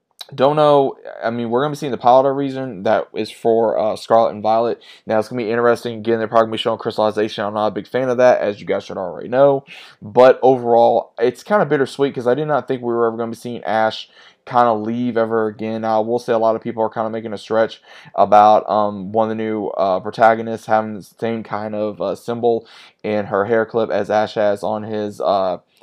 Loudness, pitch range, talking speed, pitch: -18 LUFS, 110-125 Hz, 255 wpm, 115 Hz